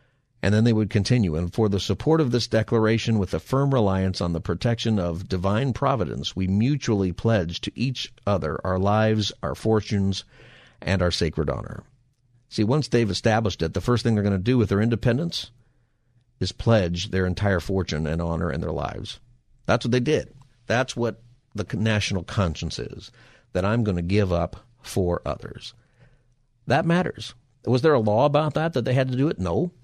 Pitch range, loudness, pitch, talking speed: 95-125 Hz, -24 LUFS, 110 Hz, 190 wpm